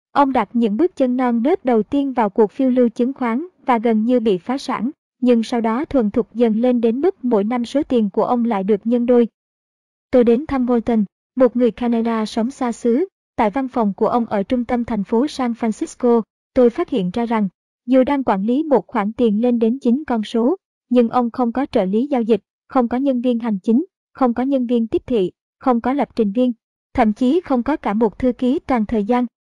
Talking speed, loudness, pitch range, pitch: 235 wpm, -18 LUFS, 230-255 Hz, 245 Hz